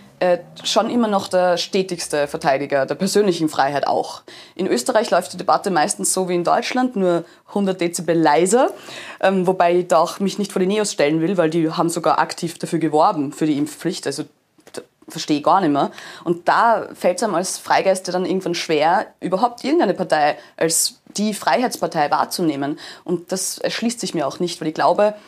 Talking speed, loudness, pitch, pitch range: 190 wpm, -19 LUFS, 180 Hz, 160-195 Hz